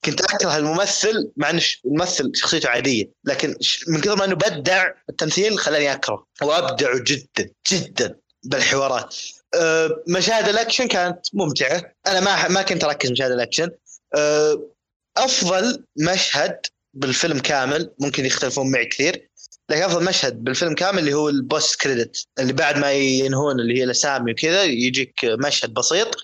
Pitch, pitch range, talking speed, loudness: 155 Hz, 135-185 Hz, 145 wpm, -19 LUFS